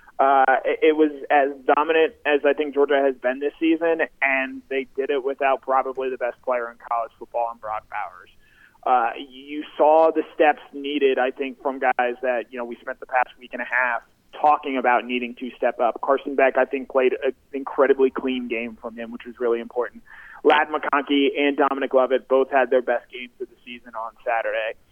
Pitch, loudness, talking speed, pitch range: 135 Hz, -22 LUFS, 205 wpm, 125-145 Hz